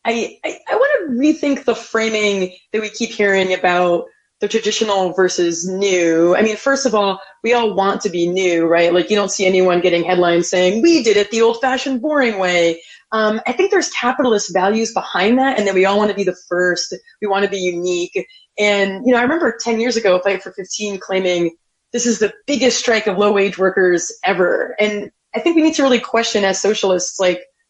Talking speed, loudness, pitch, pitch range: 215 wpm, -16 LUFS, 205 Hz, 185-235 Hz